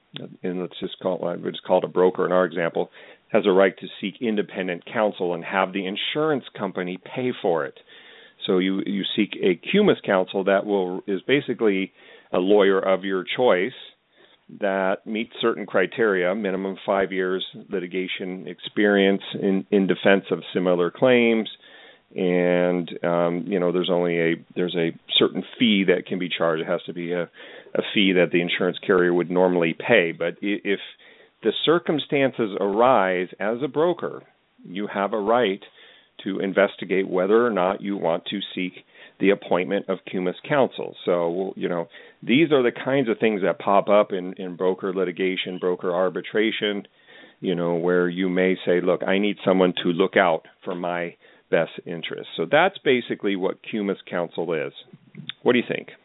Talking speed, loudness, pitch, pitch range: 170 wpm, -23 LUFS, 95 Hz, 90-100 Hz